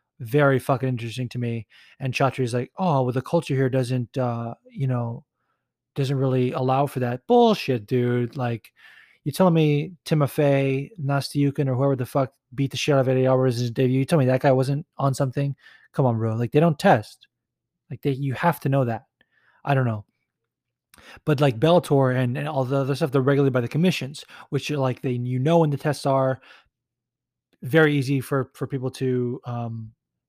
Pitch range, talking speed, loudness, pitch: 125-145 Hz, 195 wpm, -23 LUFS, 135 Hz